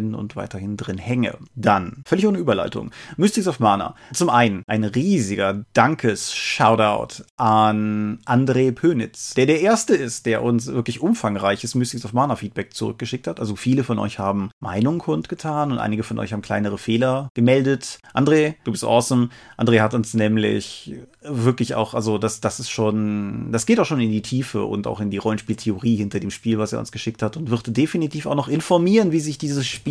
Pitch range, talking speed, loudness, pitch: 105-130 Hz, 190 wpm, -21 LUFS, 115 Hz